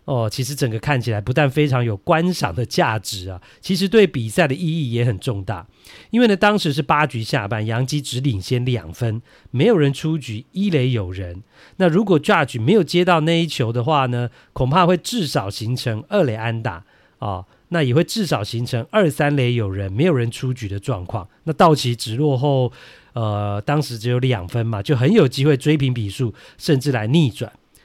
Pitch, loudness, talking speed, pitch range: 130 Hz, -19 LUFS, 295 characters per minute, 115-155 Hz